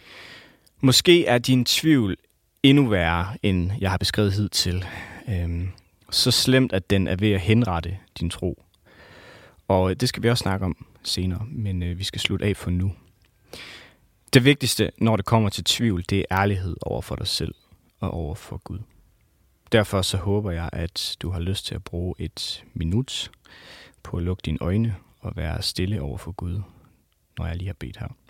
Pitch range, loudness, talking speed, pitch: 90-110 Hz, -23 LUFS, 180 wpm, 95 Hz